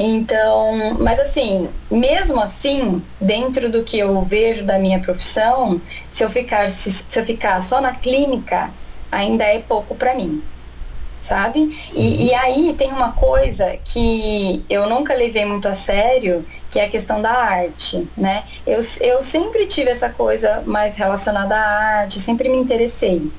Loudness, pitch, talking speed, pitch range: -17 LUFS, 220 Hz, 160 wpm, 195-255 Hz